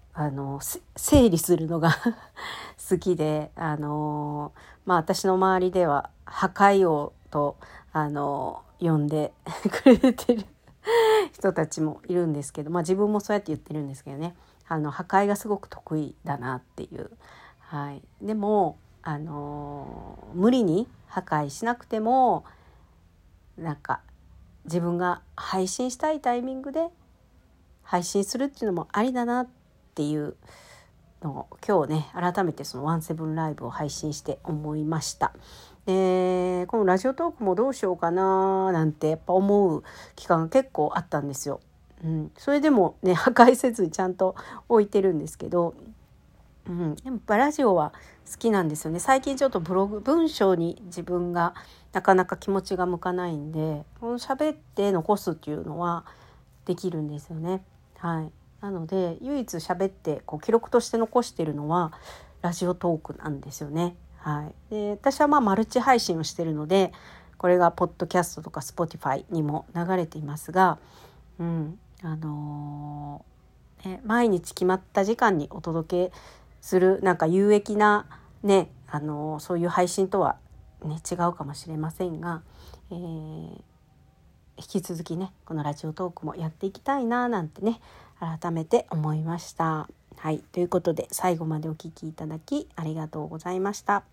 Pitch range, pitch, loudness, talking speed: 155-200 Hz, 175 Hz, -26 LUFS, 315 characters per minute